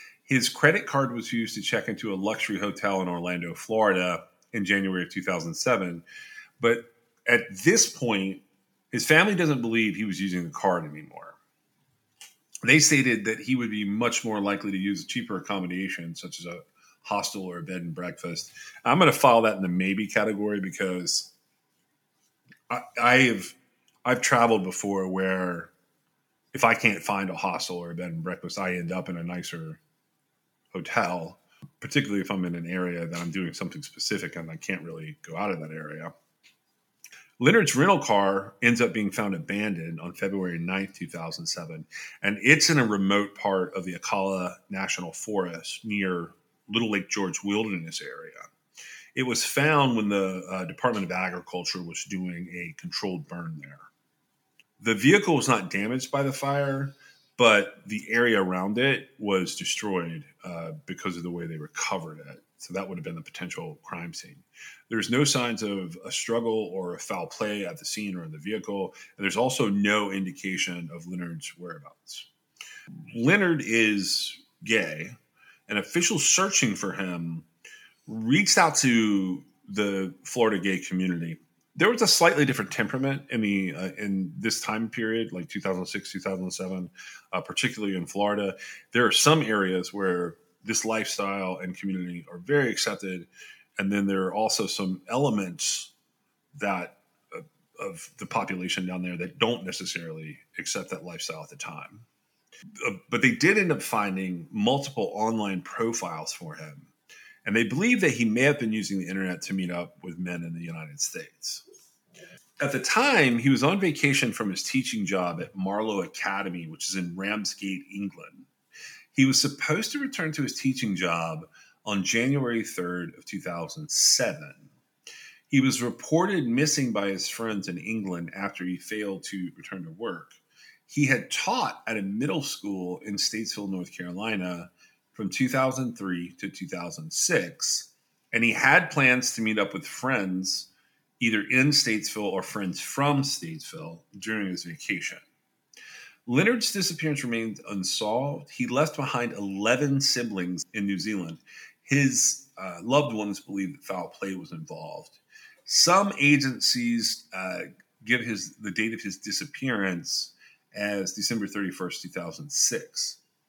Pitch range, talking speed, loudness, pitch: 90-125 Hz, 160 wpm, -26 LUFS, 100 Hz